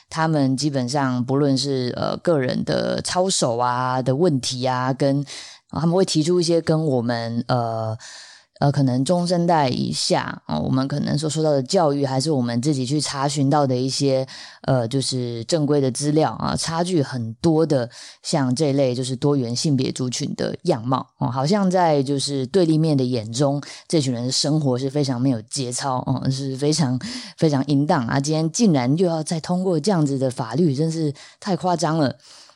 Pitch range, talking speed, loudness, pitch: 130-160 Hz, 275 characters per minute, -21 LUFS, 140 Hz